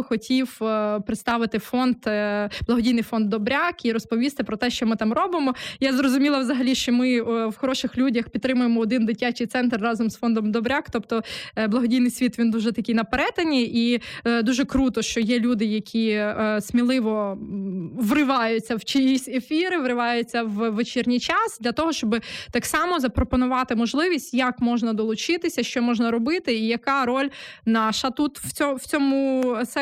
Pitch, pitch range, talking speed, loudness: 240 Hz, 230-260 Hz, 150 wpm, -23 LUFS